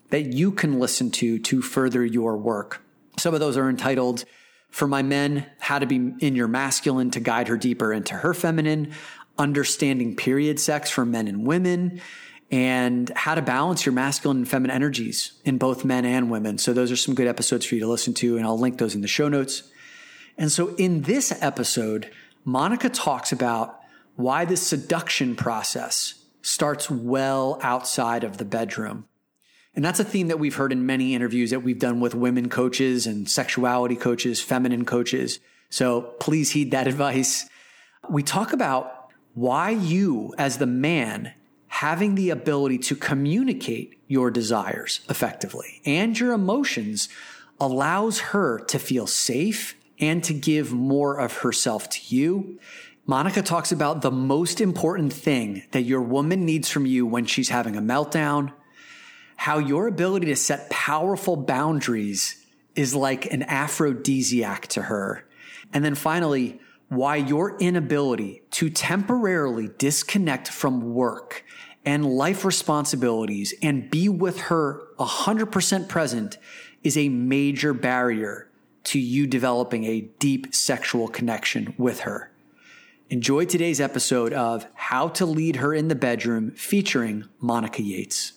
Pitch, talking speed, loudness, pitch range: 140 Hz, 150 wpm, -23 LUFS, 125-160 Hz